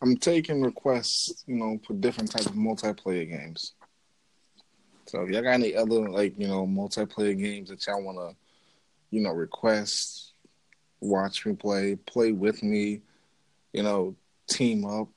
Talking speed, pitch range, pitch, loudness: 150 wpm, 100-115 Hz, 105 Hz, -28 LUFS